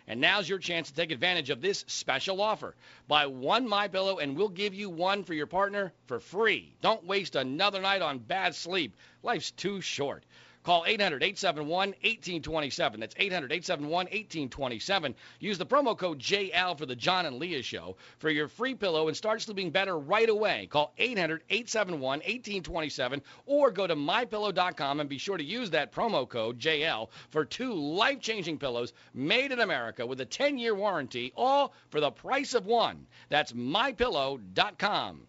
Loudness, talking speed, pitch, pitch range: -30 LUFS, 160 wpm, 180 Hz, 150-205 Hz